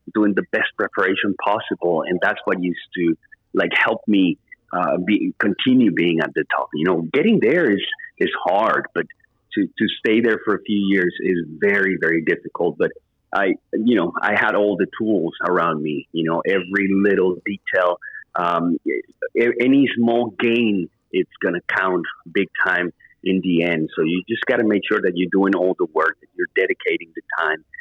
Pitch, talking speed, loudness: 110 Hz, 185 wpm, -20 LUFS